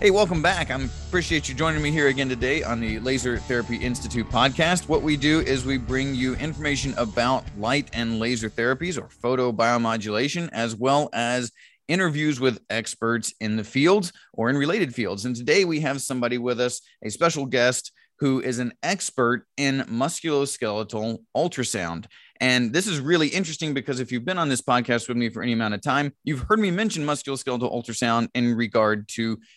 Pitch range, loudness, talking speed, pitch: 120-145 Hz, -24 LUFS, 185 wpm, 130 Hz